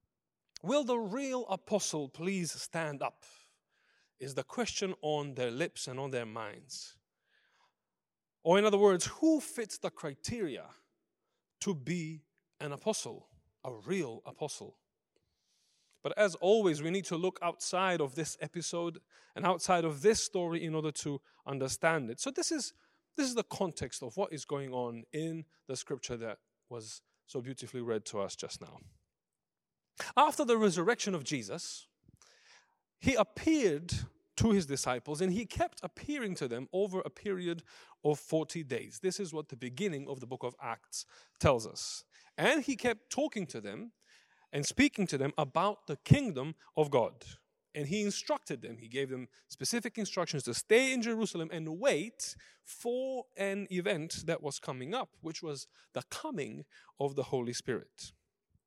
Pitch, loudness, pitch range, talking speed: 170 Hz, -34 LUFS, 145-210 Hz, 160 wpm